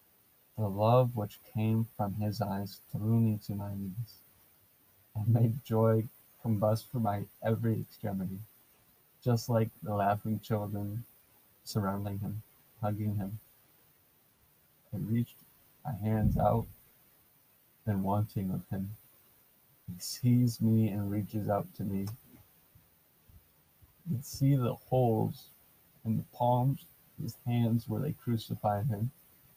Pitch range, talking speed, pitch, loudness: 100-120 Hz, 125 wpm, 110 Hz, -33 LUFS